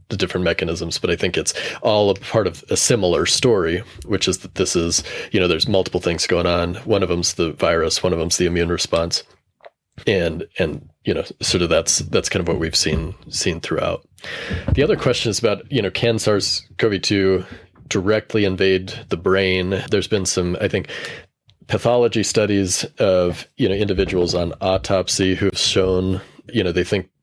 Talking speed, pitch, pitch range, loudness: 185 wpm, 95 Hz, 90-105 Hz, -19 LUFS